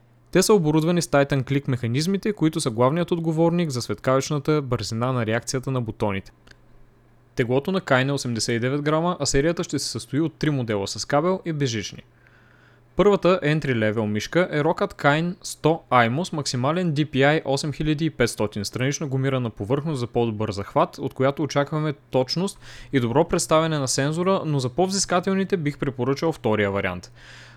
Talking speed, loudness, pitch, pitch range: 155 wpm, -23 LUFS, 140 Hz, 125-160 Hz